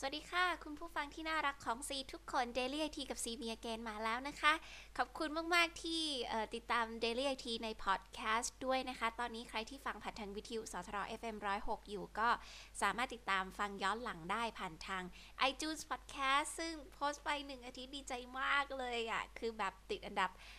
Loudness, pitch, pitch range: -40 LUFS, 240 Hz, 220-285 Hz